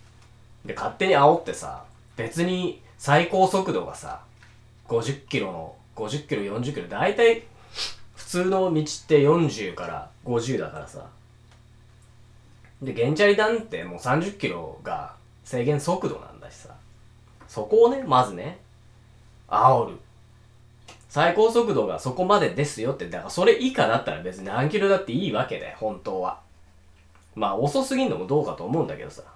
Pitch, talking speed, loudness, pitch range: 120 Hz, 270 characters per minute, -24 LUFS, 115-170 Hz